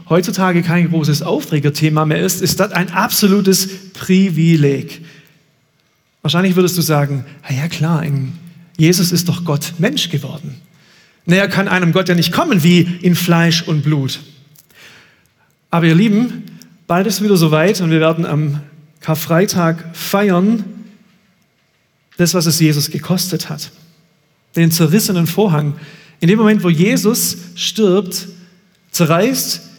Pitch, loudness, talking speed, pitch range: 170 Hz, -14 LUFS, 135 wpm, 155-190 Hz